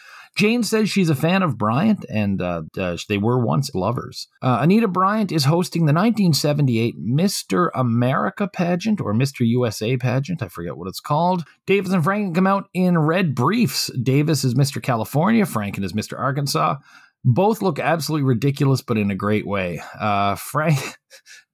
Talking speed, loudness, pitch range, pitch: 165 wpm, -20 LUFS, 120-185 Hz, 140 Hz